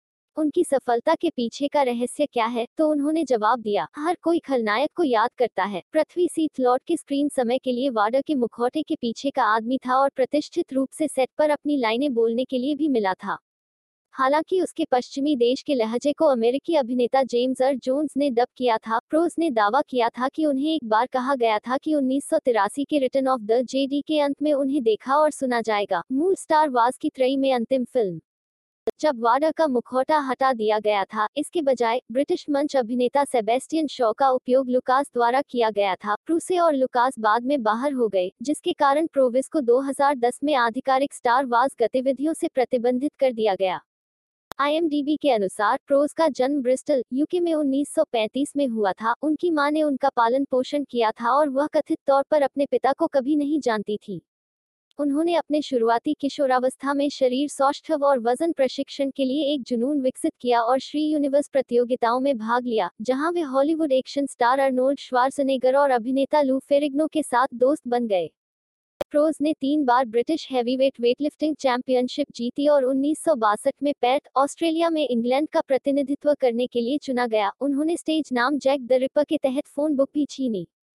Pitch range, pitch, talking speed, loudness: 245-295 Hz, 270 Hz, 185 wpm, -23 LUFS